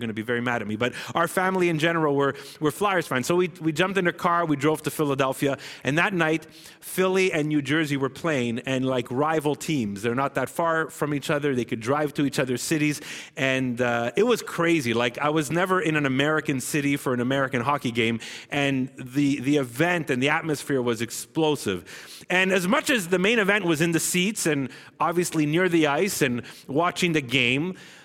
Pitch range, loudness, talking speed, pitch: 130-170 Hz, -24 LUFS, 215 wpm, 150 Hz